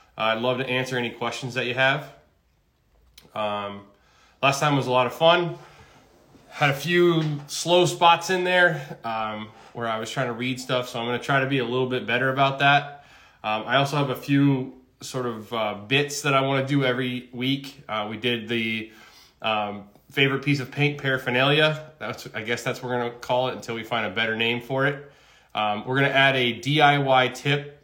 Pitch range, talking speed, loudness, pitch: 120-140 Hz, 215 wpm, -23 LUFS, 130 Hz